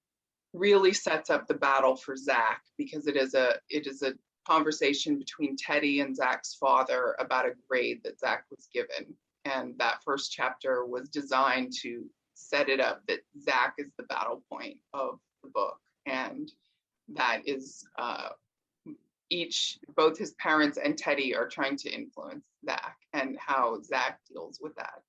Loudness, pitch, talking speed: -30 LUFS, 185 Hz, 160 wpm